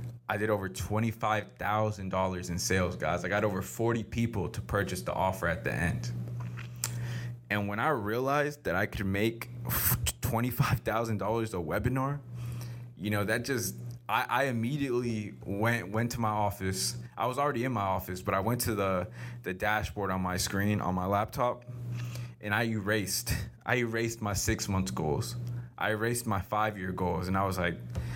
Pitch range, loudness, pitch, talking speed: 95-120 Hz, -32 LUFS, 110 Hz, 170 wpm